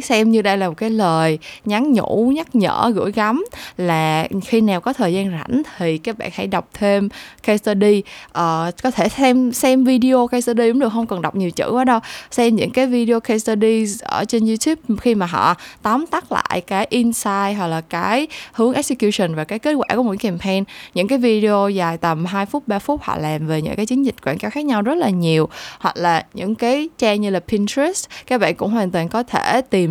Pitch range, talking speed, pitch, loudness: 190-250 Hz, 225 wpm, 220 Hz, -18 LUFS